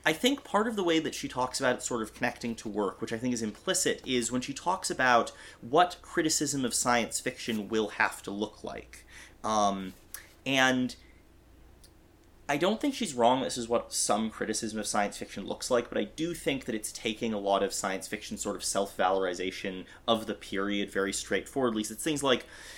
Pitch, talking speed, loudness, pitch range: 110 Hz, 205 wpm, -30 LUFS, 95-130 Hz